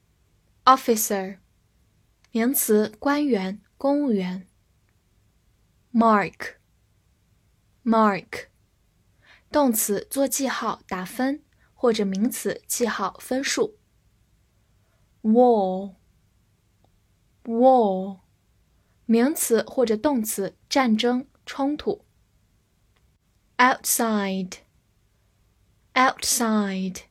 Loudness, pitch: -23 LUFS, 210 Hz